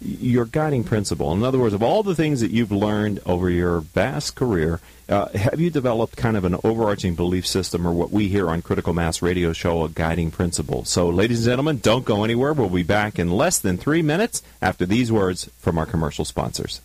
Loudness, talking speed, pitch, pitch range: -21 LUFS, 215 wpm, 100 Hz, 85-115 Hz